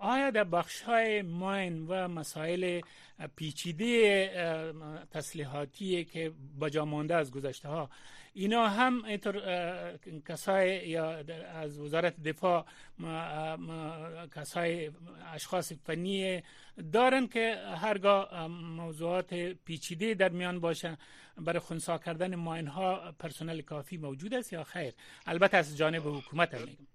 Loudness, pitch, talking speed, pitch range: -33 LUFS, 170 Hz, 115 wpm, 155-185 Hz